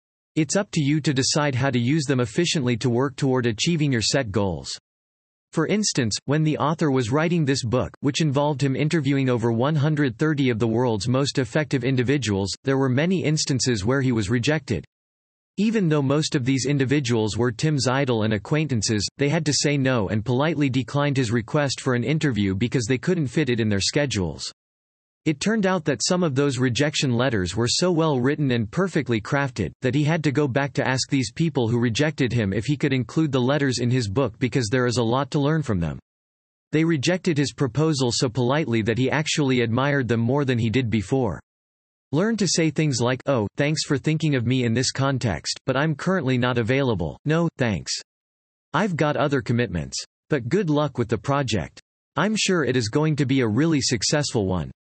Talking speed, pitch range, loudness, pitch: 200 wpm, 120-150 Hz, -22 LUFS, 135 Hz